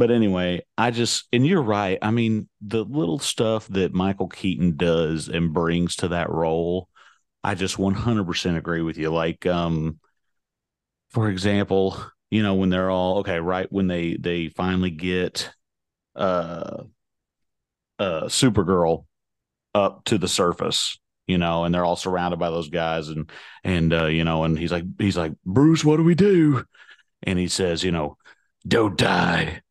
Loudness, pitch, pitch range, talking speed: -22 LUFS, 90 Hz, 85-105 Hz, 165 wpm